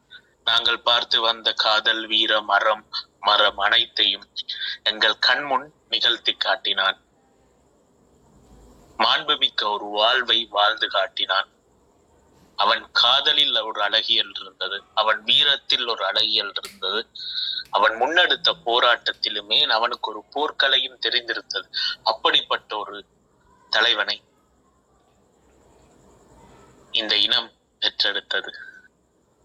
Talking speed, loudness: 80 wpm, -20 LUFS